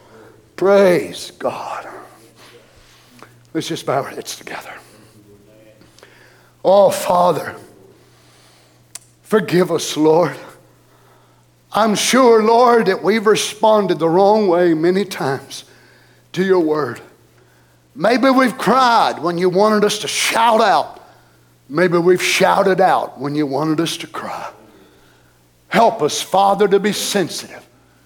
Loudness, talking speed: -15 LUFS, 115 wpm